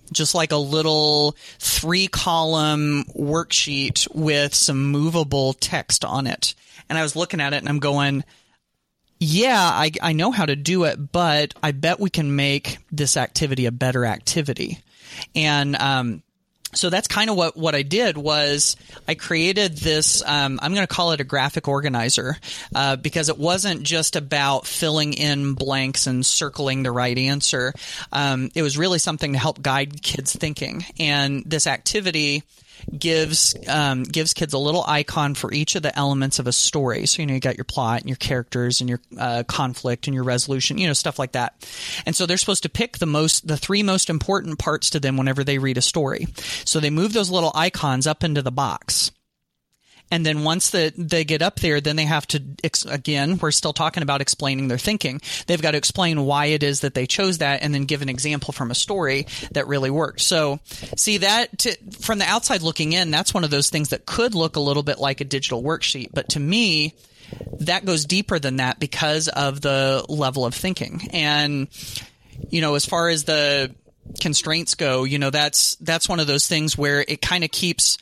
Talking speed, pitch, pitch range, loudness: 200 wpm, 150 Hz, 135-165 Hz, -20 LUFS